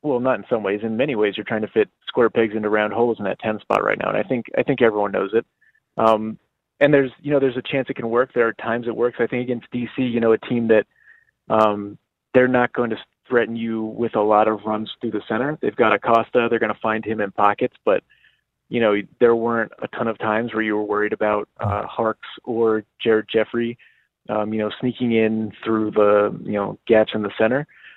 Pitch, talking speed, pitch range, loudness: 110 Hz, 240 wpm, 105-120 Hz, -21 LUFS